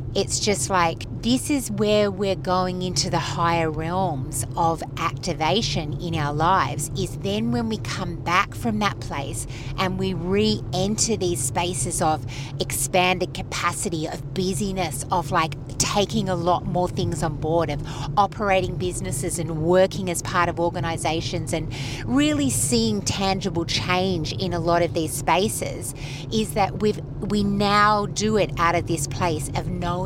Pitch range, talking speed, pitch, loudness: 140-185 Hz, 155 wpm, 165 Hz, -23 LUFS